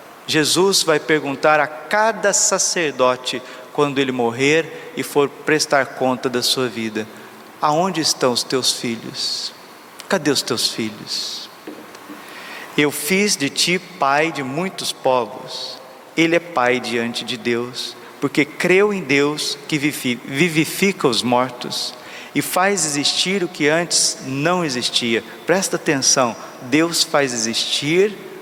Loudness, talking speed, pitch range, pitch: -18 LUFS, 125 wpm, 125-165 Hz, 145 Hz